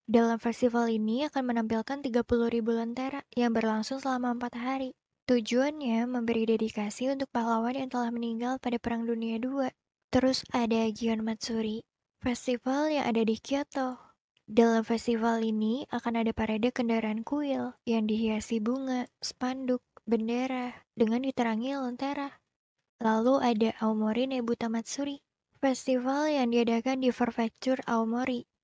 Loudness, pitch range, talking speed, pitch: -30 LUFS, 230-260 Hz, 130 wpm, 240 Hz